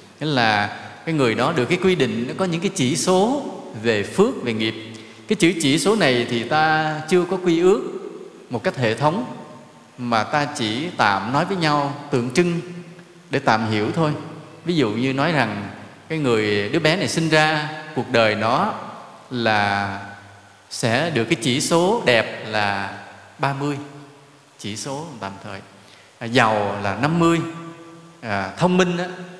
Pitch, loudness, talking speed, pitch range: 140 Hz, -20 LUFS, 170 wpm, 110-165 Hz